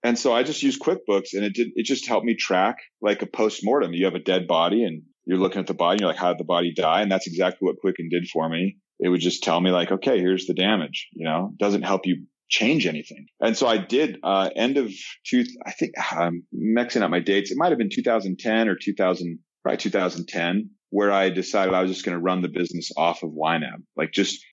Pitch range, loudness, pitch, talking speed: 85-100 Hz, -23 LUFS, 95 Hz, 245 wpm